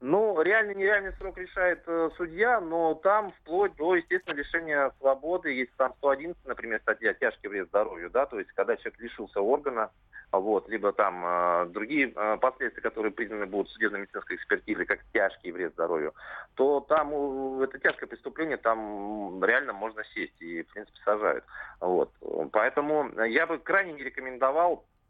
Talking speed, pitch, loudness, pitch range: 165 wpm, 160 Hz, -28 LUFS, 130-195 Hz